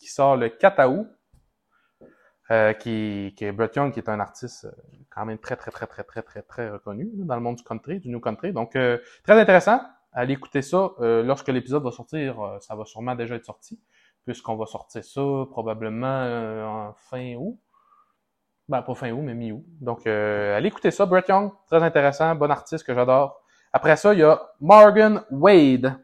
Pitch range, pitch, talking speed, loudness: 115-155 Hz, 125 Hz, 200 wpm, -21 LUFS